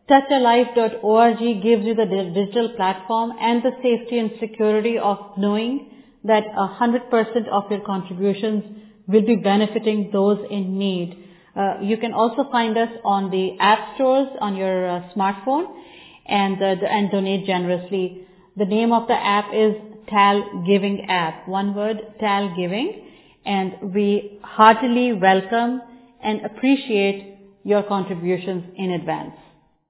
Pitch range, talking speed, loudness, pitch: 195-230 Hz, 135 wpm, -20 LUFS, 210 Hz